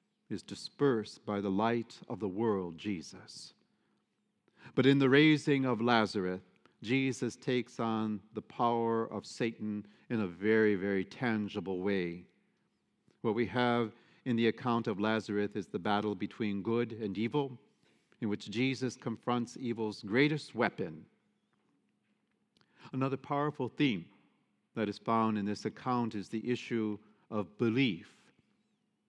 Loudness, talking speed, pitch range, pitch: -33 LUFS, 130 wpm, 105-125 Hz, 115 Hz